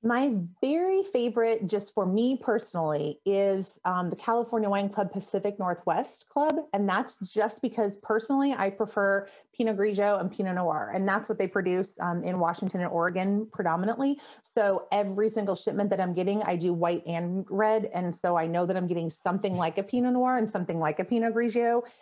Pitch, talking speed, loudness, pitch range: 200 Hz, 190 wpm, -28 LUFS, 180-225 Hz